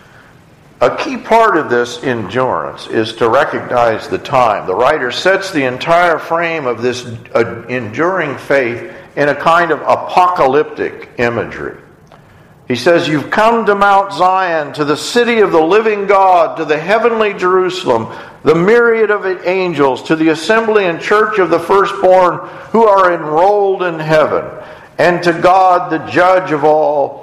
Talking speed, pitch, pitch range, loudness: 150 wpm, 180 Hz, 155-200 Hz, -12 LUFS